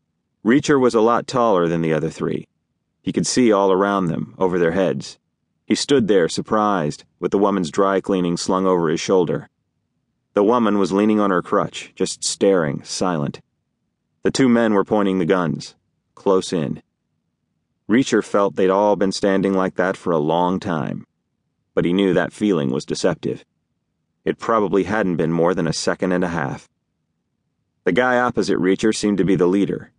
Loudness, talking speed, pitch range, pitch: -19 LUFS, 180 wpm, 90-100 Hz, 95 Hz